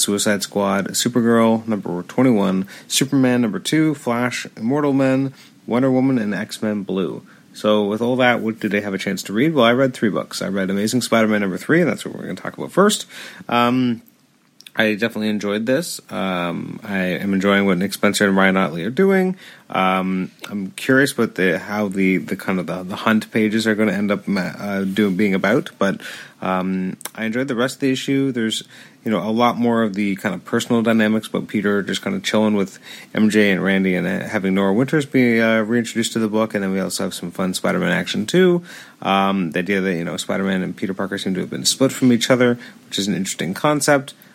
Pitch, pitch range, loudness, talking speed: 110 Hz, 95-125 Hz, -19 LUFS, 225 wpm